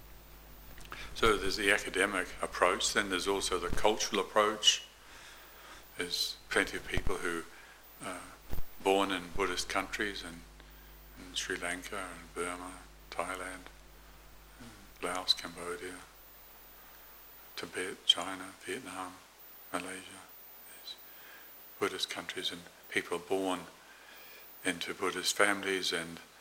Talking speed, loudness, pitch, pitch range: 100 wpm, -33 LUFS, 90 Hz, 85-95 Hz